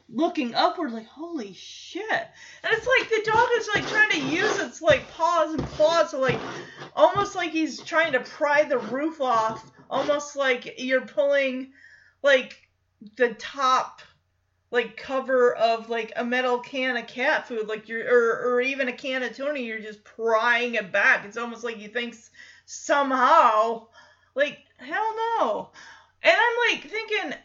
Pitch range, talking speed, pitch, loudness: 240-325 Hz, 165 wpm, 270 Hz, -24 LUFS